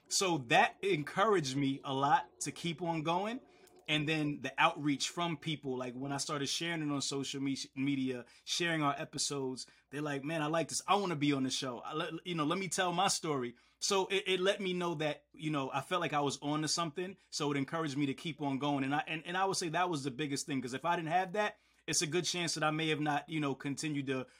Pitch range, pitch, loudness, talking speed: 140-175 Hz, 155 Hz, -34 LUFS, 265 wpm